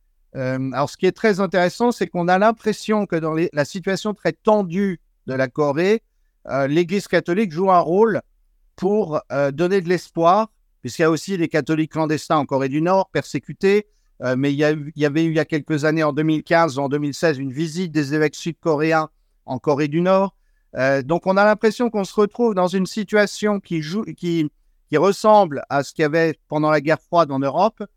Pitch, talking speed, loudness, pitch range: 170 Hz, 210 wpm, -20 LUFS, 150-195 Hz